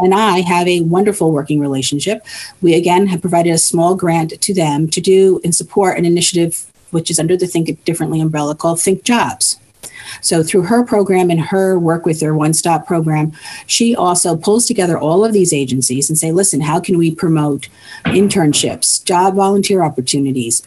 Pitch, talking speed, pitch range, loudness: 170 Hz, 180 wpm, 155-190 Hz, -13 LUFS